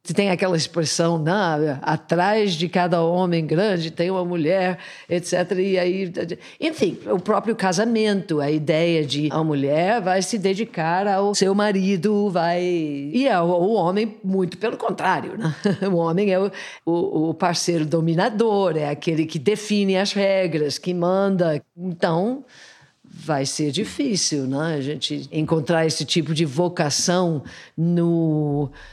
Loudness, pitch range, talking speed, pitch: -21 LUFS, 160-195 Hz, 140 wpm, 175 Hz